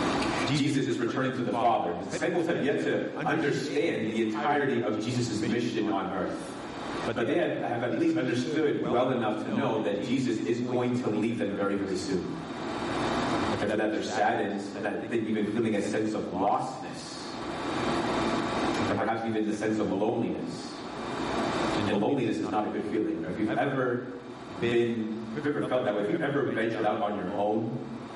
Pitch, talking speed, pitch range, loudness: 110 Hz, 185 wpm, 105-120 Hz, -29 LUFS